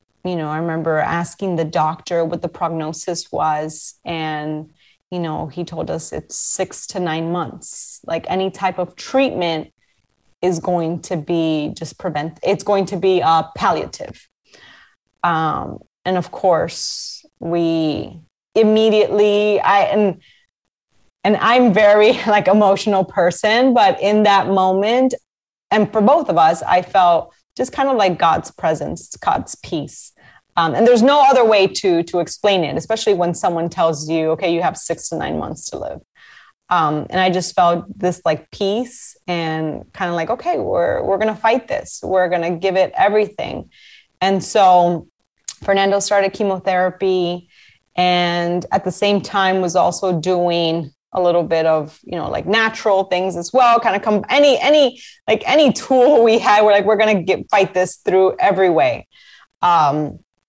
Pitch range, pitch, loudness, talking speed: 170-210 Hz, 185 Hz, -17 LUFS, 165 wpm